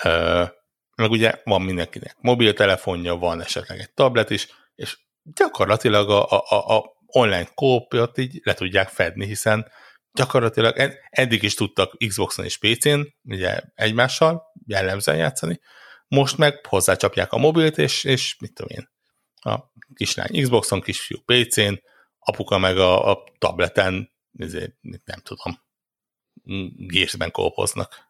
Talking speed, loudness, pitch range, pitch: 125 wpm, -20 LUFS, 95-130 Hz, 110 Hz